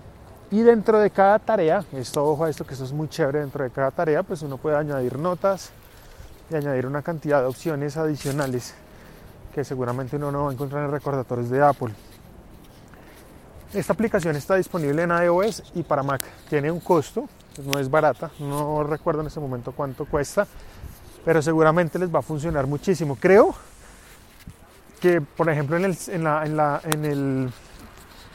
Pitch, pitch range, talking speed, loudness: 150 Hz, 135-170 Hz, 175 wpm, -23 LUFS